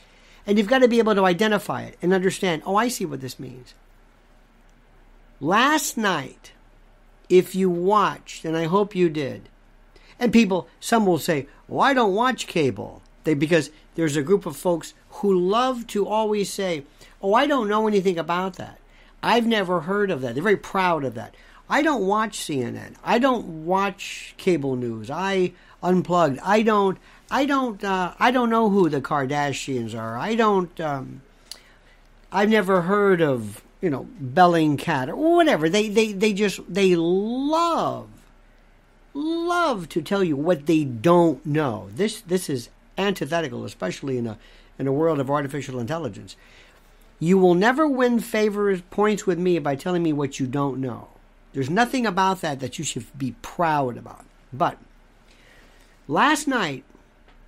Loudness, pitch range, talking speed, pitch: -22 LUFS, 145-210 Hz, 165 wpm, 180 Hz